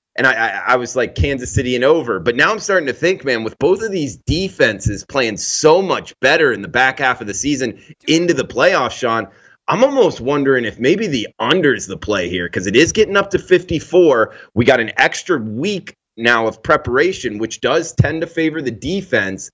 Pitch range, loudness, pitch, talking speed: 120-170 Hz, -16 LUFS, 145 Hz, 210 wpm